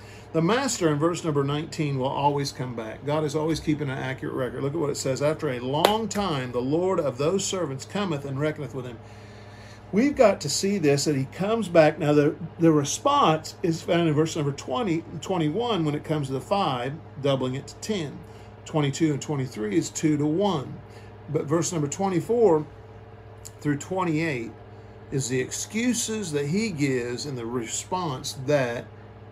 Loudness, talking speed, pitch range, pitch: -25 LUFS, 185 wpm, 125-165 Hz, 150 Hz